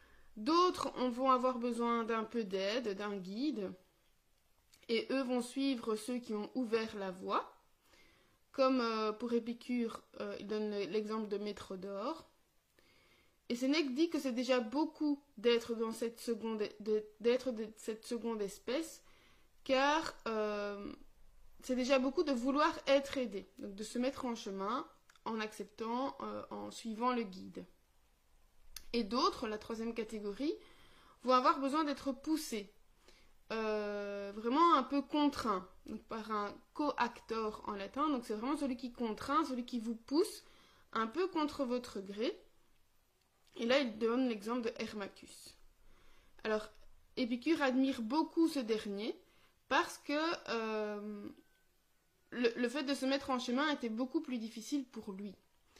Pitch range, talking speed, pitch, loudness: 215-275 Hz, 145 wpm, 235 Hz, -37 LUFS